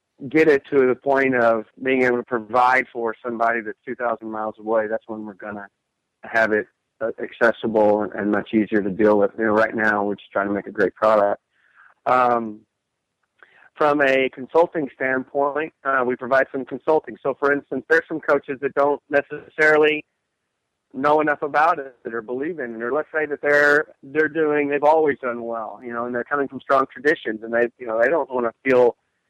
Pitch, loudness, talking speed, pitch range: 125 Hz, -21 LUFS, 195 wpm, 110-145 Hz